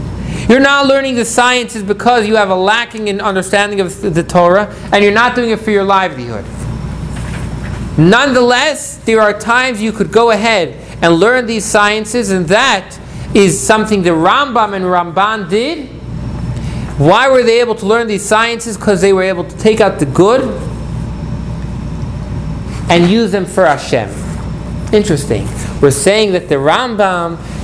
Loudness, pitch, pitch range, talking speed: -12 LUFS, 210 Hz, 185-230 Hz, 155 wpm